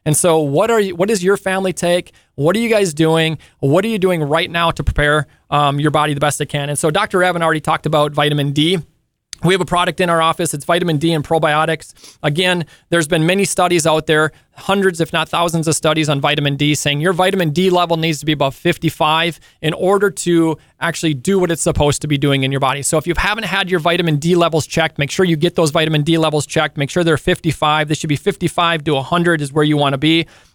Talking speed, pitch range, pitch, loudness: 245 wpm, 150-175 Hz, 160 Hz, -15 LUFS